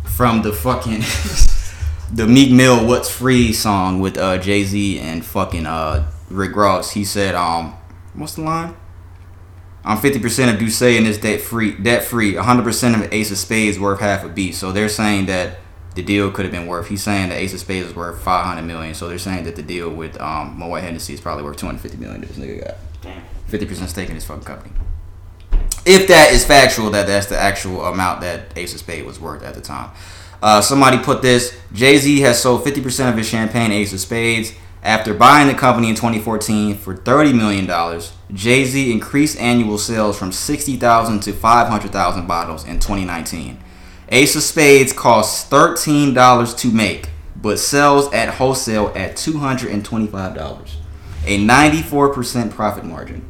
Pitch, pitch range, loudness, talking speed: 100 Hz, 90-115 Hz, -15 LUFS, 185 wpm